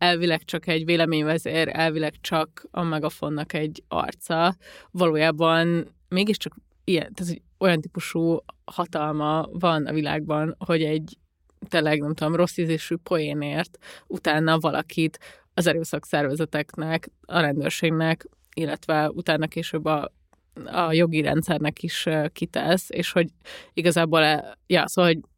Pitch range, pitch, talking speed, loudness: 155-175 Hz, 160 Hz, 120 wpm, -24 LUFS